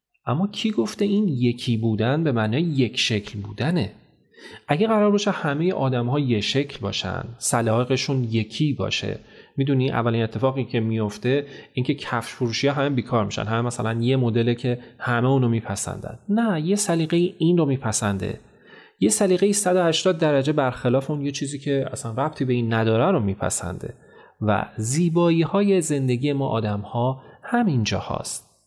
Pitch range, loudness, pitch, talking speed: 115-155 Hz, -23 LUFS, 130 Hz, 155 wpm